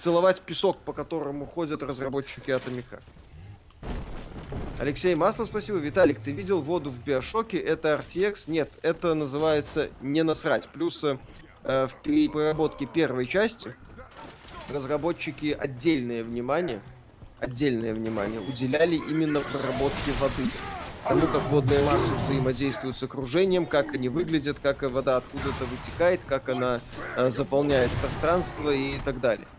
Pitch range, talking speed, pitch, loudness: 130-160 Hz, 120 wpm, 140 Hz, -27 LUFS